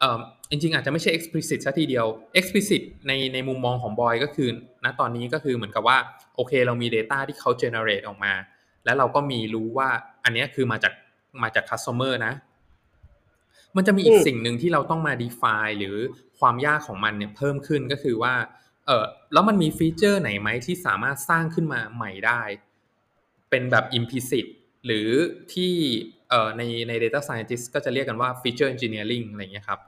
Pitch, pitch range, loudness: 130 Hz, 115-150 Hz, -24 LUFS